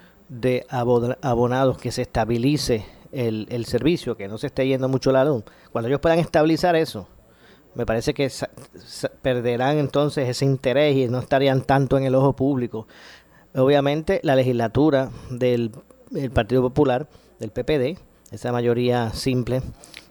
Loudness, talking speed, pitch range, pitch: -22 LUFS, 150 wpm, 120-140 Hz, 130 Hz